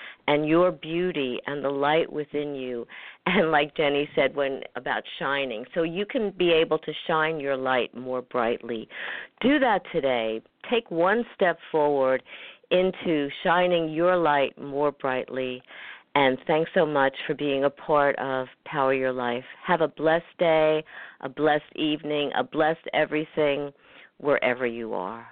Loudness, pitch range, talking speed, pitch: -25 LUFS, 135-160 Hz, 150 wpm, 145 Hz